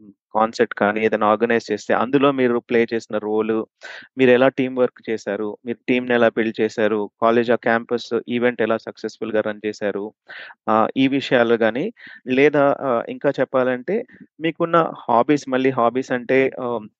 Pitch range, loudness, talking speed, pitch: 110-130 Hz, -20 LUFS, 140 wpm, 115 Hz